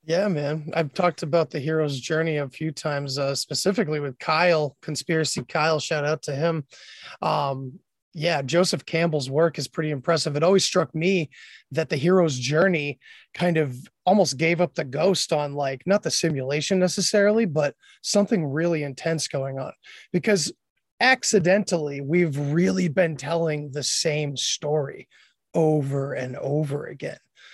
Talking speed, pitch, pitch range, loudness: 150 wpm, 160 Hz, 145-175 Hz, -23 LUFS